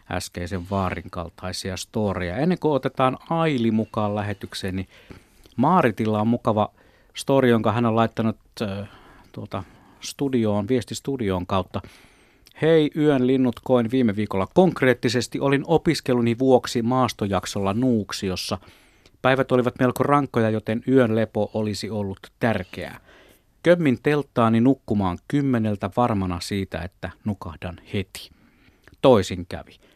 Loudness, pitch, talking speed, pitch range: -22 LUFS, 110 Hz, 115 wpm, 100-130 Hz